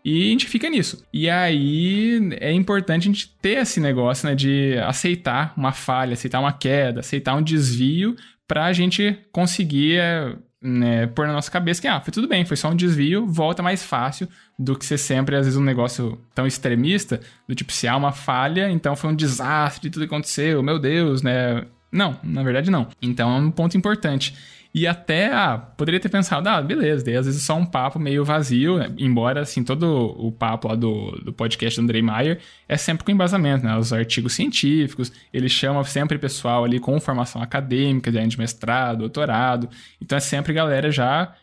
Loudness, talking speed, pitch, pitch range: -21 LUFS, 195 wpm, 140 Hz, 125-170 Hz